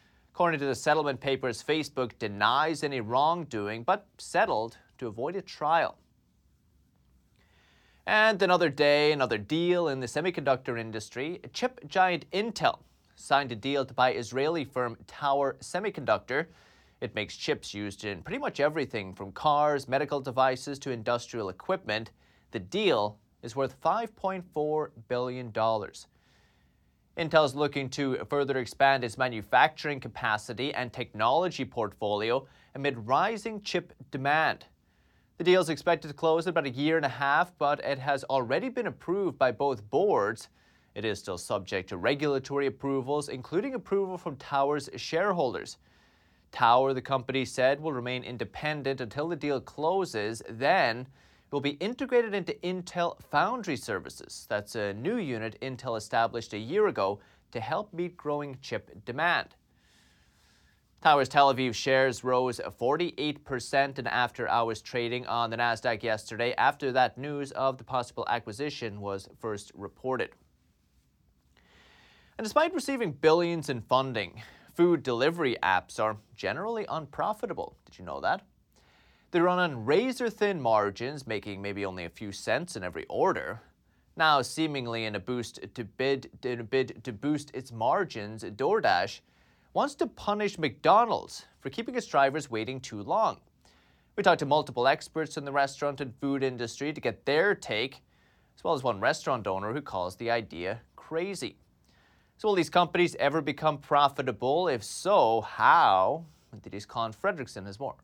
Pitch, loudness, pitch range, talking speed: 135 Hz, -29 LUFS, 115-155 Hz, 145 wpm